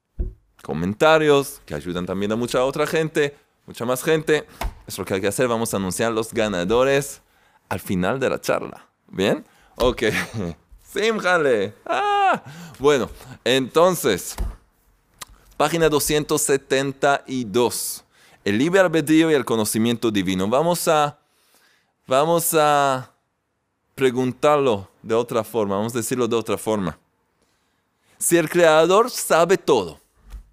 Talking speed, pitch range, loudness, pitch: 120 wpm, 115-160 Hz, -20 LUFS, 140 Hz